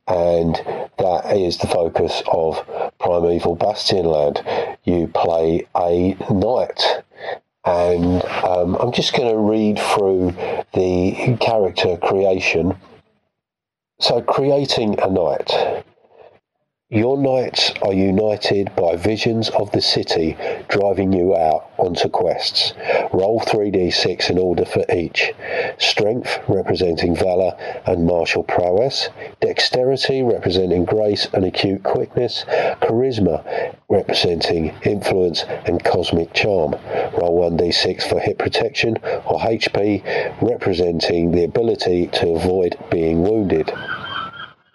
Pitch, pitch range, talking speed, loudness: 90 Hz, 85-105 Hz, 105 wpm, -18 LUFS